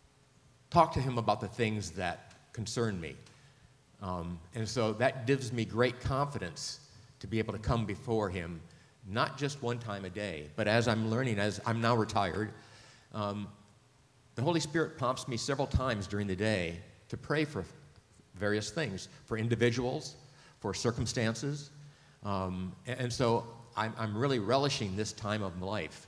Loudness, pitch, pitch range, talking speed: -34 LUFS, 115 Hz, 105-130 Hz, 165 wpm